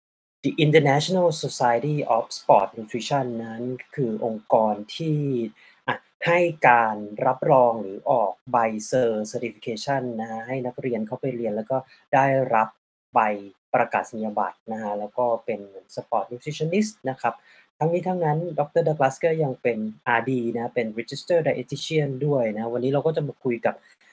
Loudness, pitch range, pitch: -24 LUFS, 115-145 Hz, 125 Hz